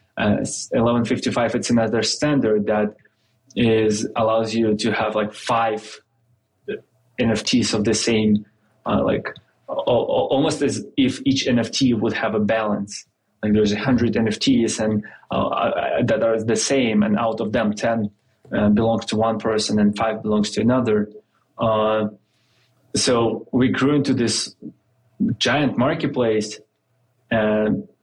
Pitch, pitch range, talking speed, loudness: 110 Hz, 110-120 Hz, 140 wpm, -20 LUFS